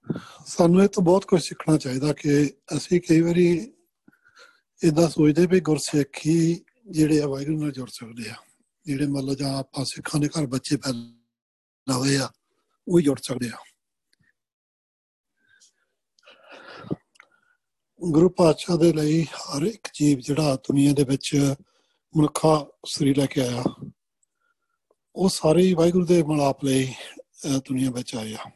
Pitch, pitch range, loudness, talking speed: 155 Hz, 135-175 Hz, -23 LUFS, 125 wpm